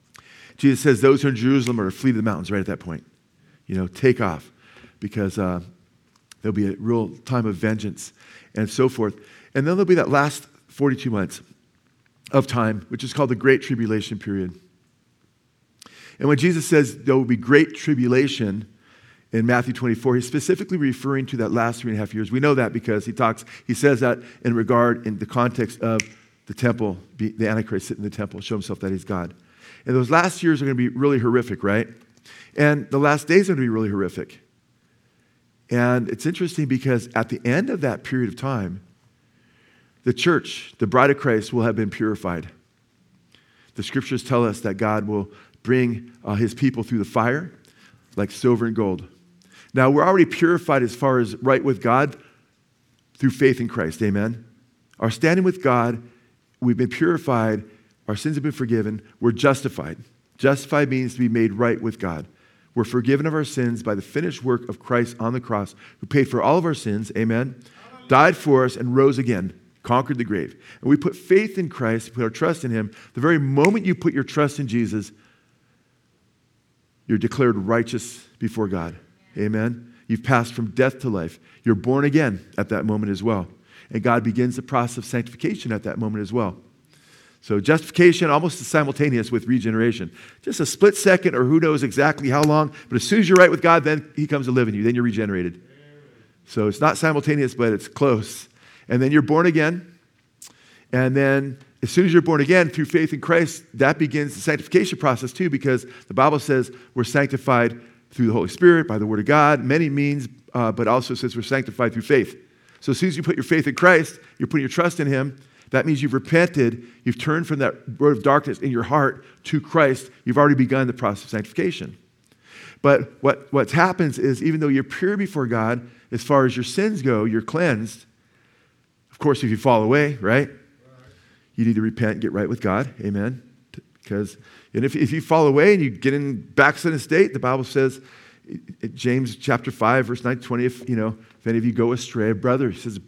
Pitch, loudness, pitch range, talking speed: 125 Hz, -21 LUFS, 115-145 Hz, 200 wpm